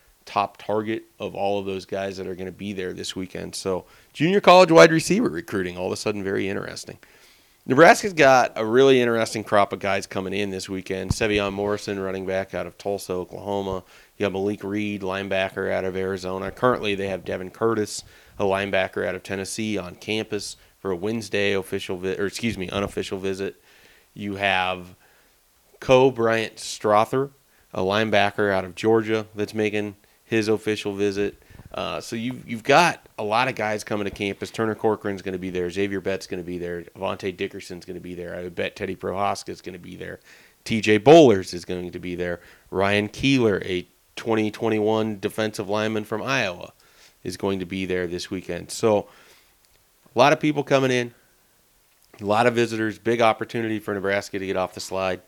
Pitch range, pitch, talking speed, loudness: 95-110 Hz, 100 Hz, 190 wpm, -23 LUFS